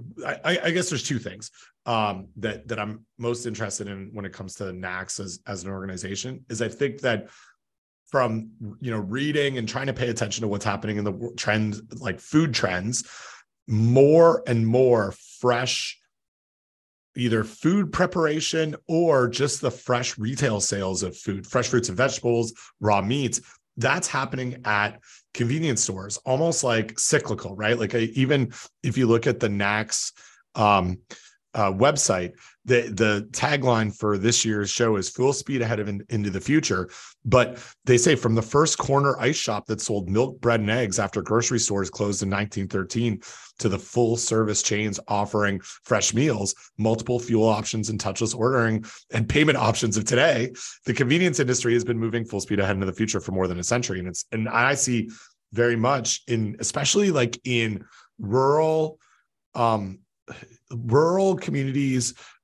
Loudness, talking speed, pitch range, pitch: -24 LUFS, 165 wpm, 105-125 Hz, 115 Hz